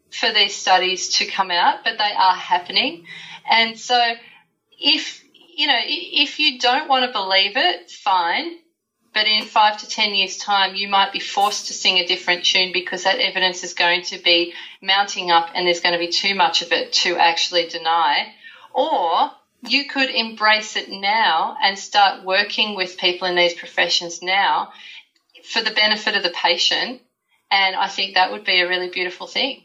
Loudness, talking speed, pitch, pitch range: -18 LUFS, 185 wpm, 200 Hz, 180-245 Hz